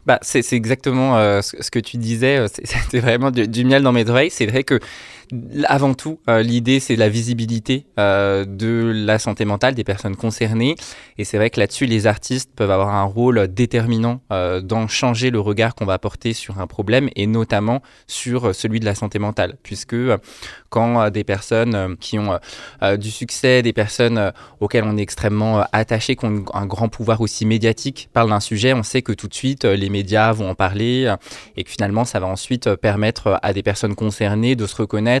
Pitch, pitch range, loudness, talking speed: 115 Hz, 105-120 Hz, -18 LUFS, 195 wpm